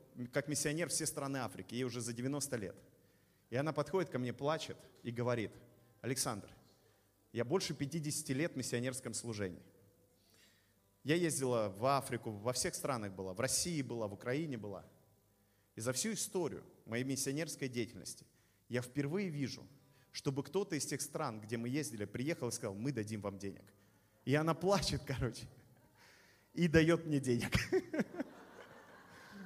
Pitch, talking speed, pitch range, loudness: 125 Hz, 150 wpm, 110-145 Hz, -38 LUFS